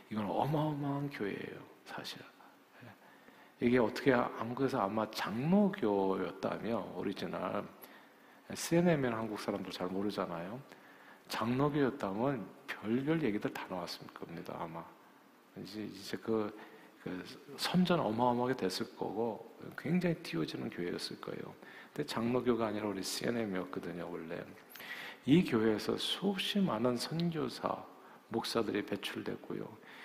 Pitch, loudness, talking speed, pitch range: 120 Hz, -36 LUFS, 285 characters per minute, 105-145 Hz